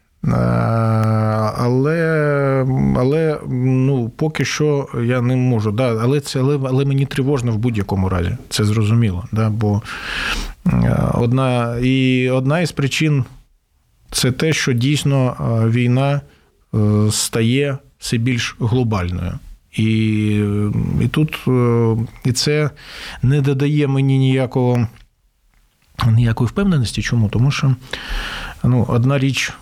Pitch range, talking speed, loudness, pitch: 110-135 Hz, 105 wpm, -17 LUFS, 125 Hz